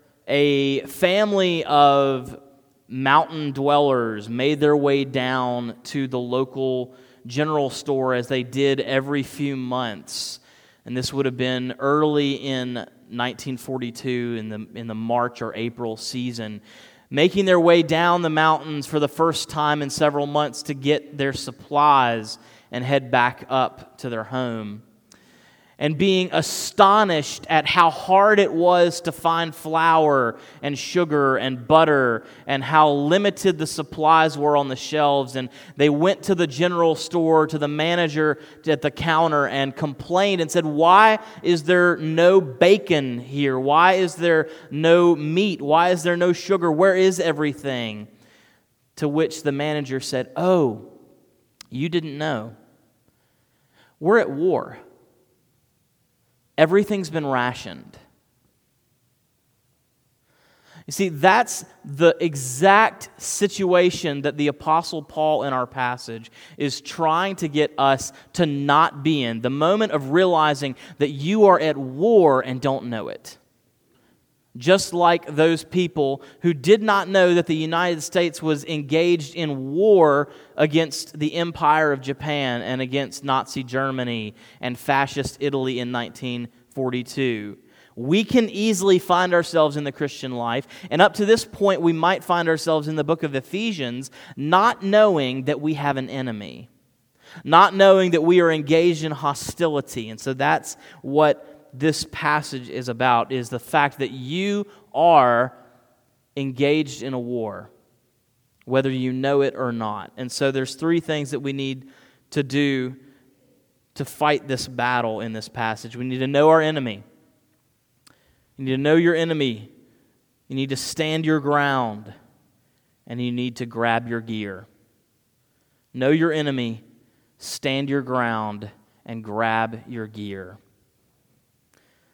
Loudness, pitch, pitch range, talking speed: -20 LUFS, 145 Hz, 125-165 Hz, 145 wpm